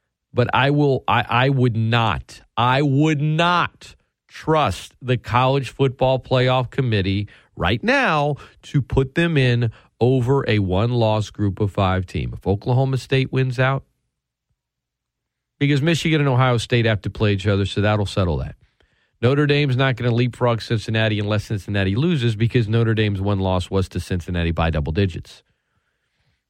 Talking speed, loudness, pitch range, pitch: 160 wpm, -20 LUFS, 100-135 Hz, 120 Hz